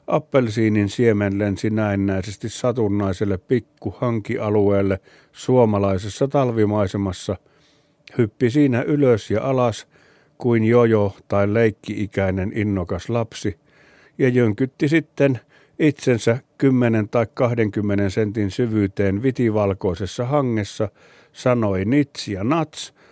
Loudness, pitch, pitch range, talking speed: -20 LUFS, 115 Hz, 100-130 Hz, 90 wpm